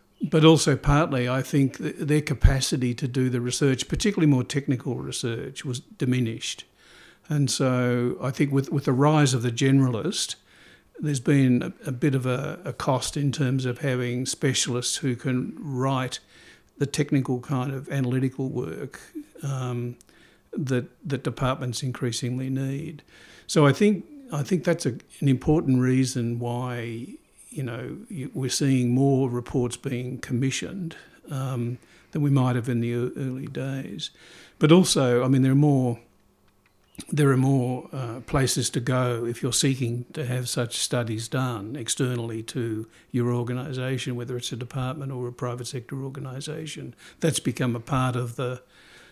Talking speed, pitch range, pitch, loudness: 155 wpm, 125-145 Hz, 130 Hz, -25 LUFS